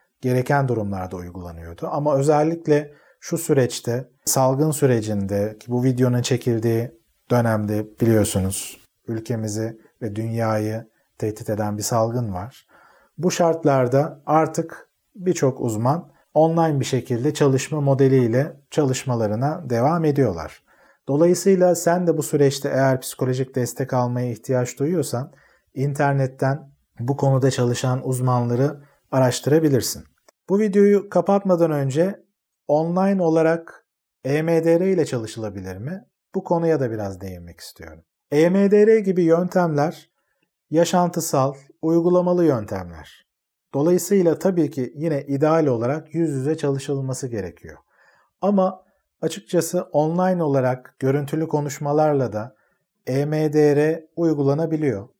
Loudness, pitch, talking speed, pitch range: -21 LUFS, 140 Hz, 100 wpm, 120-160 Hz